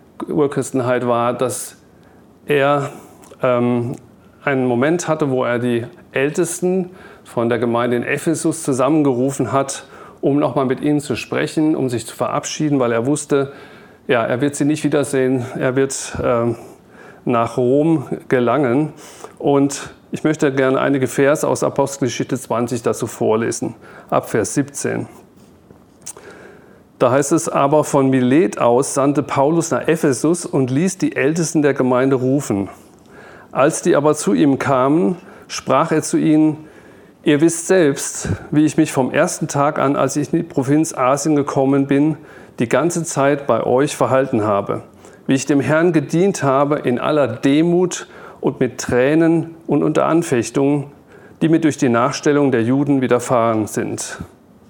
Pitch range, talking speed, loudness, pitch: 130-155 Hz, 150 wpm, -17 LUFS, 140 Hz